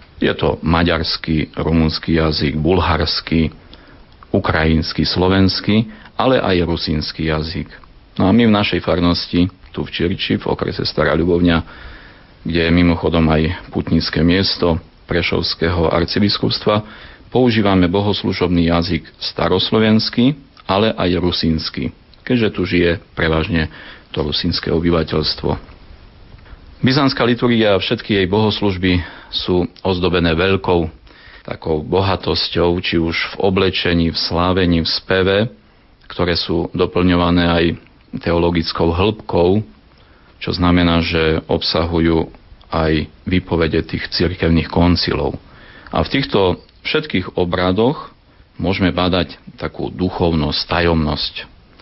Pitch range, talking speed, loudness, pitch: 80-95 Hz, 105 wpm, -17 LUFS, 85 Hz